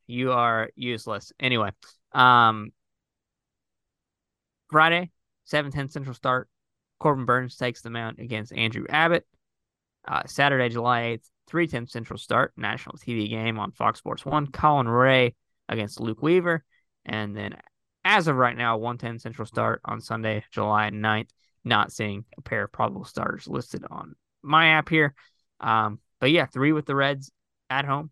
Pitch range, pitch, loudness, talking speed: 110-140 Hz, 120 Hz, -24 LUFS, 155 wpm